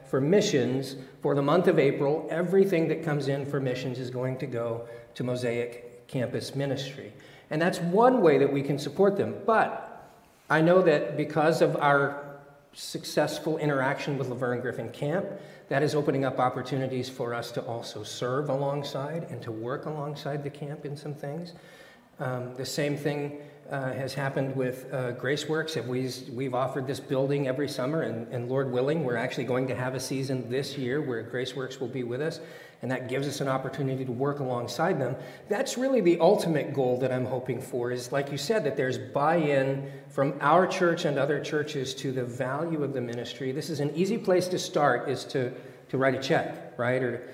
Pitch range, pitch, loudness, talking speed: 130-150 Hz, 140 Hz, -28 LUFS, 190 wpm